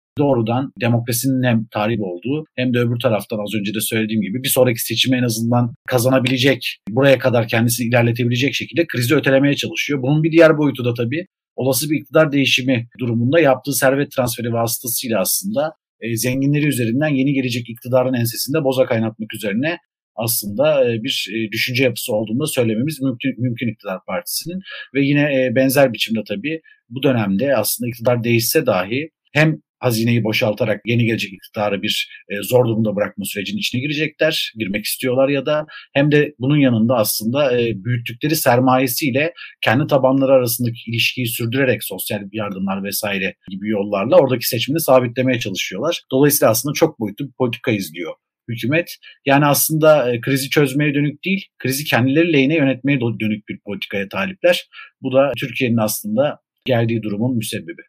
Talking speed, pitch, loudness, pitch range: 150 wpm, 125 Hz, -18 LUFS, 115-140 Hz